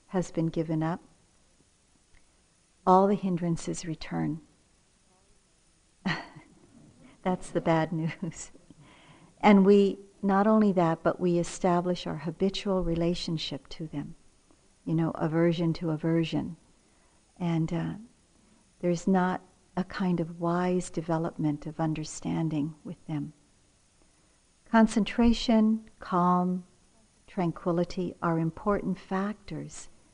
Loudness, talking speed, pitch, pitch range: -28 LUFS, 100 wpm, 175 Hz, 165-190 Hz